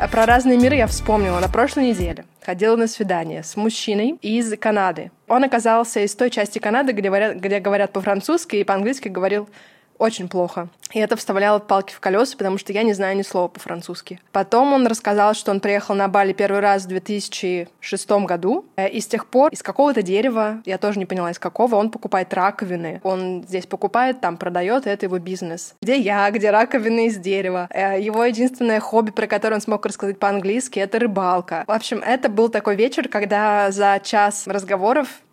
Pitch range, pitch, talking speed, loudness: 195-225 Hz, 205 Hz, 185 wpm, -19 LUFS